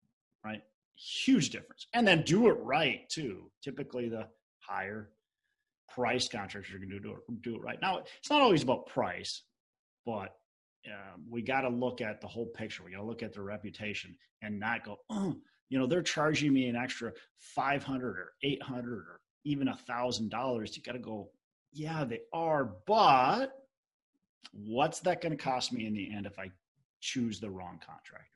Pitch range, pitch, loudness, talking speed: 105-140 Hz, 120 Hz, -33 LUFS, 185 wpm